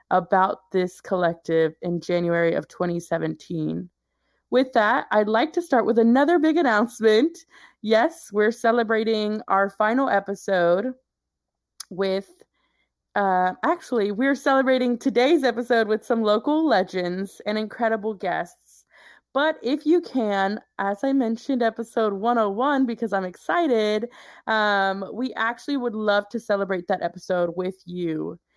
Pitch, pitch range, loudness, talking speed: 220 Hz, 190-255 Hz, -23 LUFS, 125 wpm